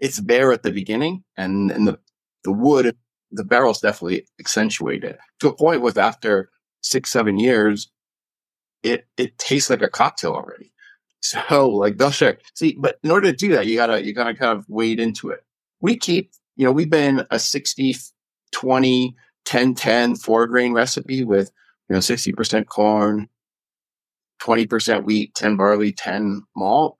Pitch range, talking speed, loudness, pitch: 105-130 Hz, 165 wpm, -19 LUFS, 115 Hz